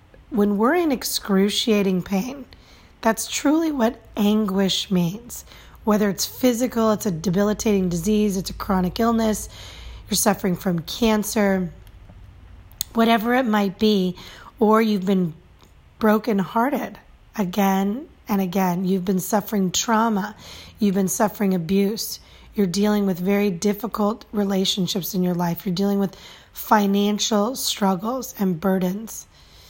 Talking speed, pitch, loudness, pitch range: 125 wpm, 205 Hz, -21 LUFS, 190-220 Hz